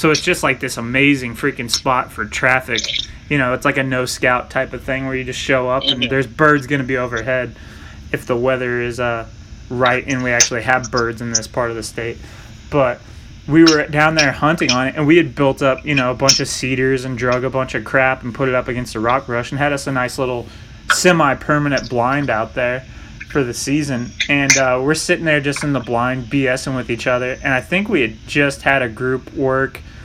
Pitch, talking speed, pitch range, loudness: 130 Hz, 240 wpm, 120-140 Hz, -17 LUFS